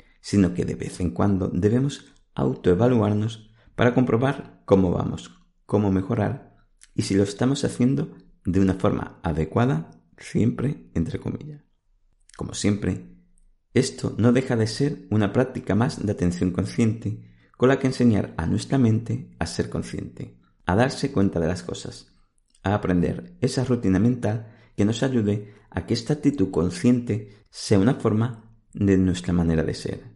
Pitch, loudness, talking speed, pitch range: 105 Hz, -24 LUFS, 150 wpm, 95-125 Hz